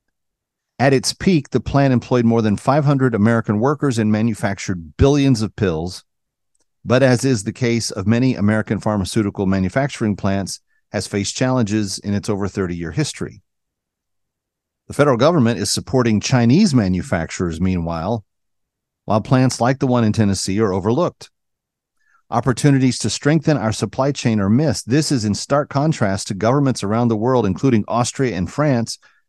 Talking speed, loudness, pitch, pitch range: 150 wpm, -18 LUFS, 115 Hz, 100-130 Hz